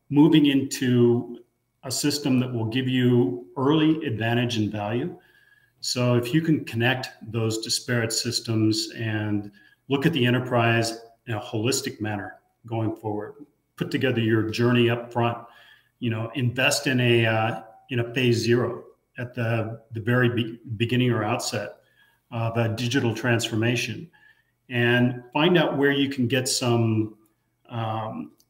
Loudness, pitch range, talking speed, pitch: -24 LUFS, 115-130 Hz, 145 wpm, 120 Hz